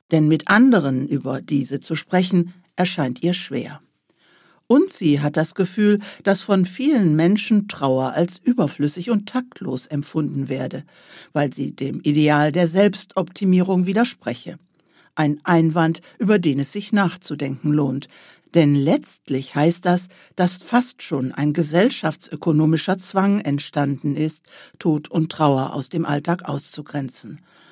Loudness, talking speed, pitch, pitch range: -20 LUFS, 130 wpm, 165 Hz, 145-190 Hz